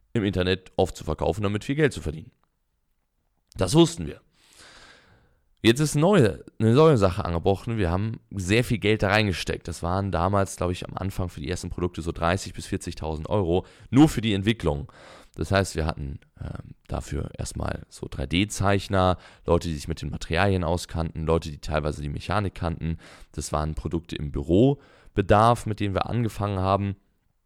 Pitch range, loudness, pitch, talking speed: 80-105 Hz, -25 LUFS, 95 Hz, 175 wpm